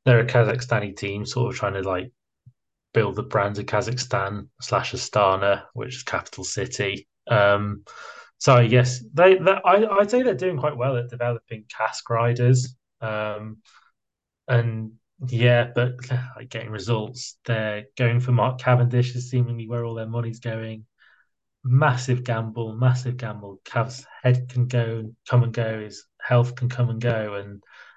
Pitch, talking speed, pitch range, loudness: 120 Hz, 155 wpm, 110-125 Hz, -23 LUFS